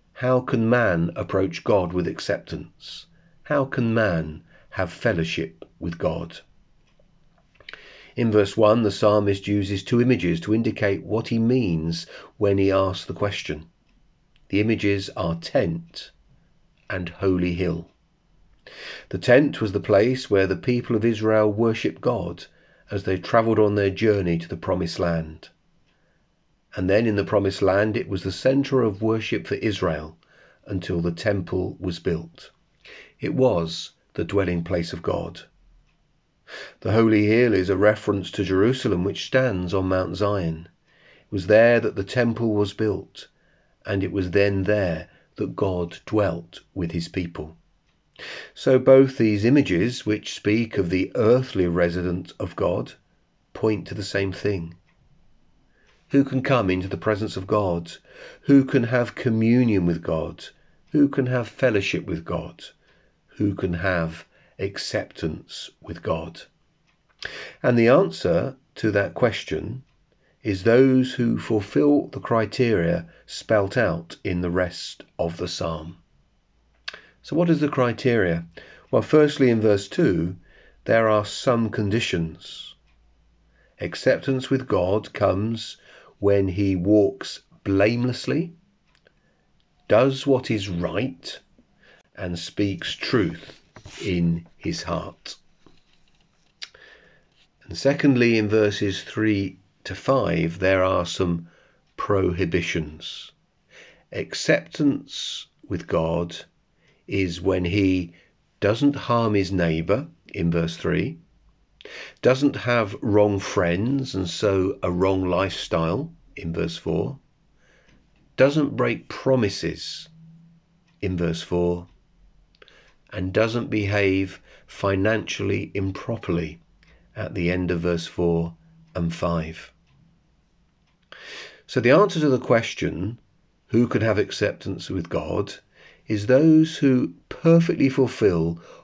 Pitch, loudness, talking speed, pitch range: 100 Hz, -23 LUFS, 125 wpm, 90-120 Hz